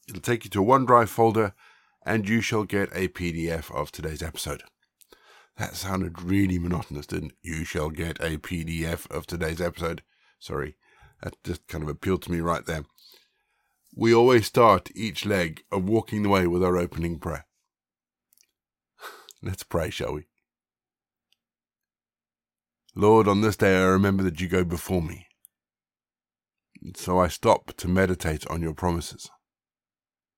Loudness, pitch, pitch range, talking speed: -25 LUFS, 90 Hz, 85-100 Hz, 150 wpm